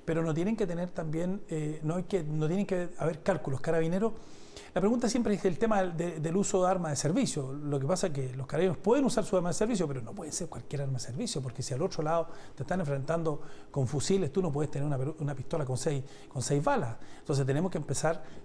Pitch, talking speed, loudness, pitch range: 165 Hz, 250 wpm, -31 LUFS, 145-185 Hz